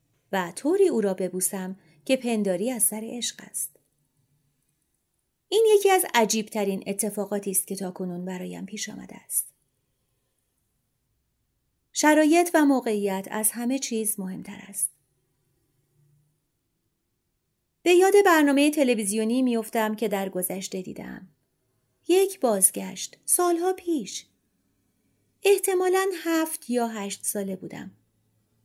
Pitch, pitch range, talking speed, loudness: 210 Hz, 180-275 Hz, 105 wpm, -24 LUFS